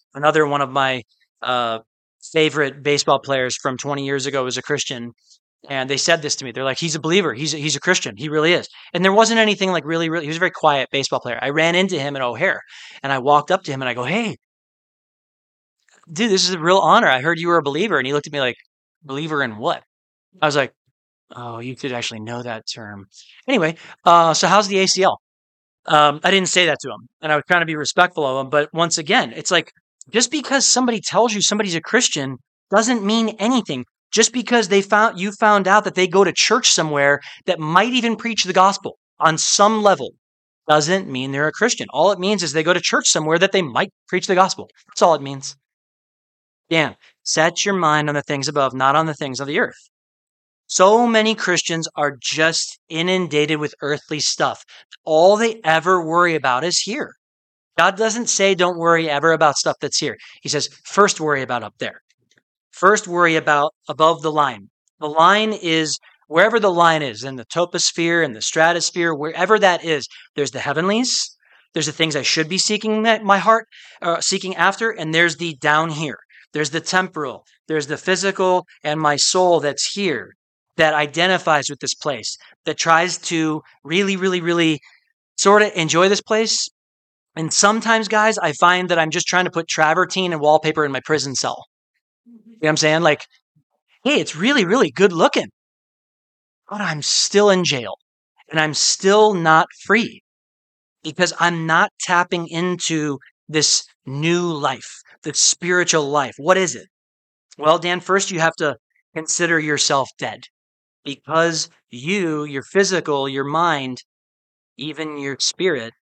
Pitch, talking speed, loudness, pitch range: 160 Hz, 190 wpm, -18 LUFS, 145-190 Hz